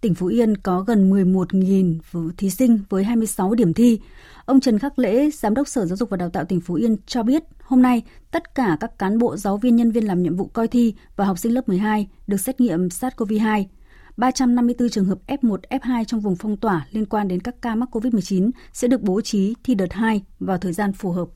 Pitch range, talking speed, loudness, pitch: 195-245 Hz, 230 wpm, -20 LUFS, 220 Hz